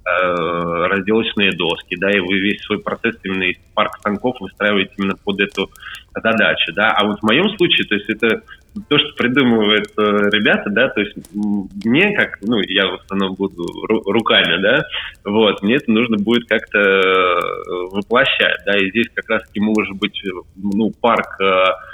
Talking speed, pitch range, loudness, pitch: 160 wpm, 95-110 Hz, -16 LUFS, 100 Hz